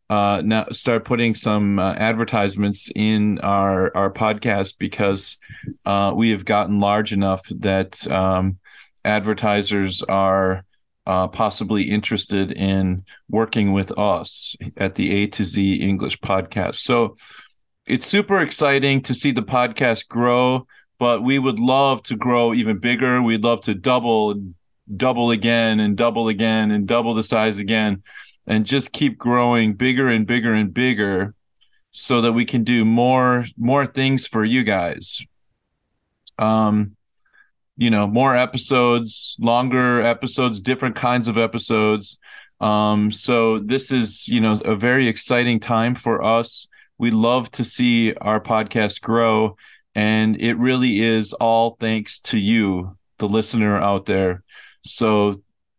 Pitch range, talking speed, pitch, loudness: 105-120 Hz, 140 wpm, 110 Hz, -19 LUFS